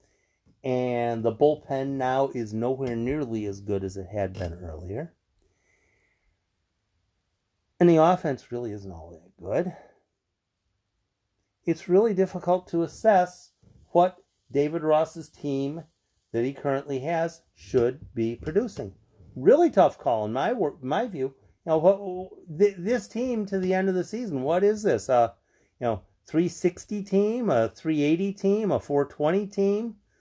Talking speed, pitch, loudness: 135 wpm, 140 Hz, -26 LUFS